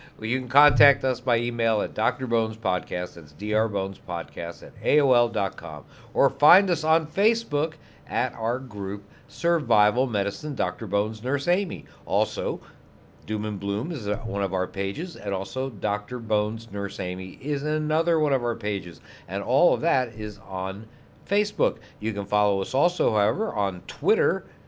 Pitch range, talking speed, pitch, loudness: 100-135 Hz, 160 wpm, 110 Hz, -25 LUFS